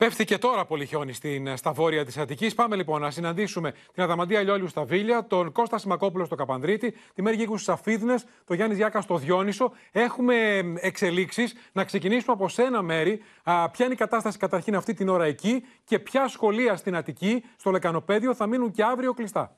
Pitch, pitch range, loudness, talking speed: 200 Hz, 175-230 Hz, -26 LUFS, 190 wpm